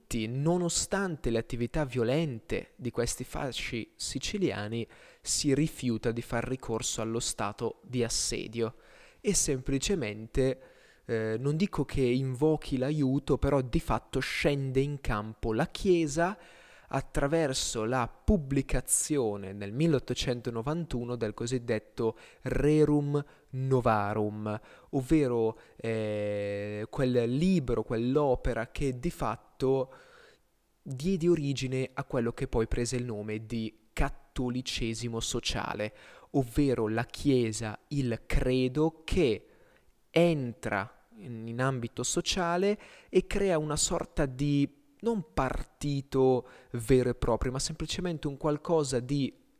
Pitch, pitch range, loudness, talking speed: 130 Hz, 115-150 Hz, -31 LUFS, 105 wpm